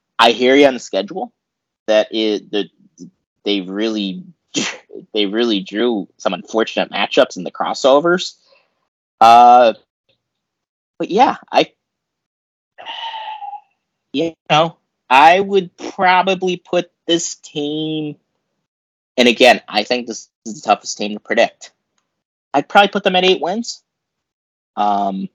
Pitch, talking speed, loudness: 145 Hz, 120 wpm, -15 LUFS